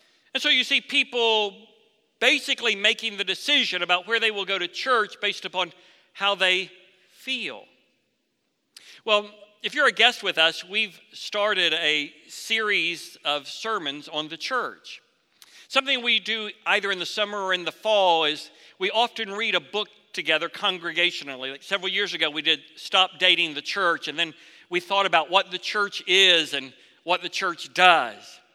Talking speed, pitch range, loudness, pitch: 170 wpm, 170-220 Hz, -23 LUFS, 195 Hz